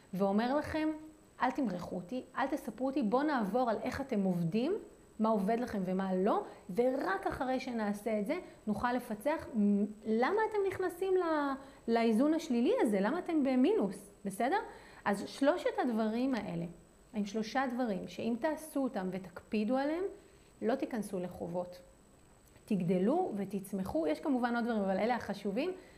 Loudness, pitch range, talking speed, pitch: -34 LUFS, 205-295 Hz, 140 wpm, 240 Hz